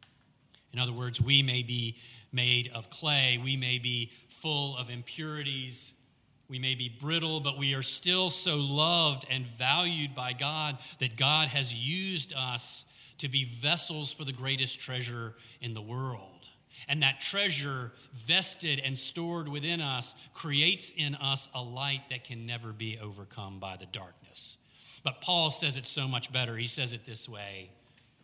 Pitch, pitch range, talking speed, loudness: 130 Hz, 120-145 Hz, 165 wpm, -29 LUFS